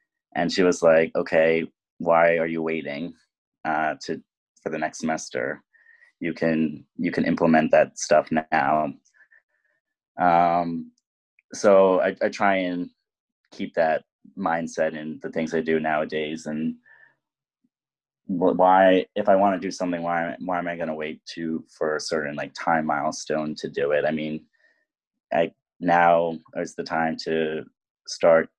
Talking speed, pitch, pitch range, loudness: 150 wpm, 80 Hz, 80-90 Hz, -23 LUFS